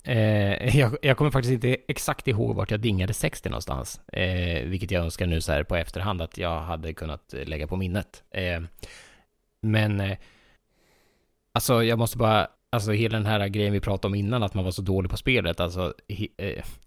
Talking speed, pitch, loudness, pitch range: 190 wpm, 100 Hz, -26 LUFS, 90-110 Hz